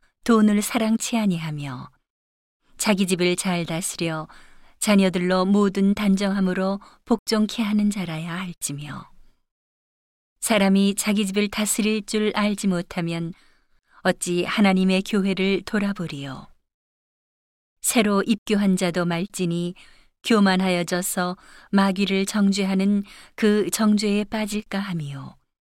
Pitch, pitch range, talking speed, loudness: 195 Hz, 175-210 Hz, 235 characters per minute, -22 LUFS